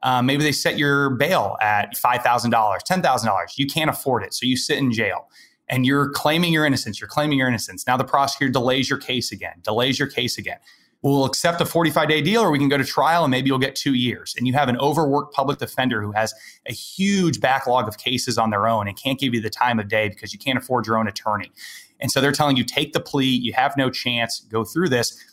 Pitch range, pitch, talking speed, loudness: 115-140 Hz, 130 Hz, 245 wpm, -20 LUFS